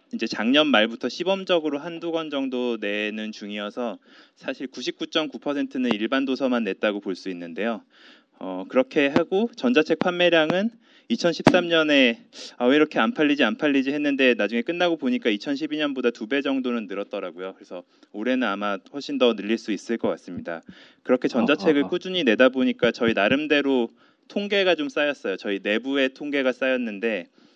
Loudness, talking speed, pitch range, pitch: -23 LUFS, 340 characters per minute, 115-170 Hz, 140 Hz